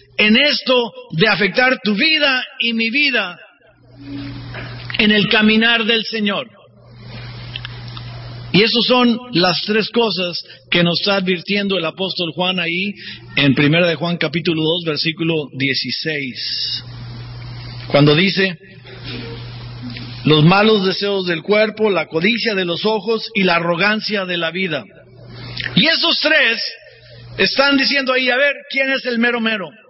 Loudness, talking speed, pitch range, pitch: -15 LUFS, 135 wpm, 130-220 Hz, 180 Hz